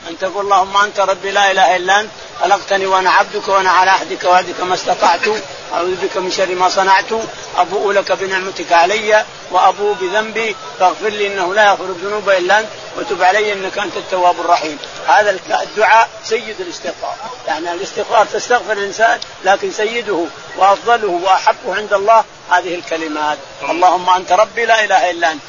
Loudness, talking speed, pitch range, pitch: -14 LUFS, 160 wpm, 180-215 Hz, 195 Hz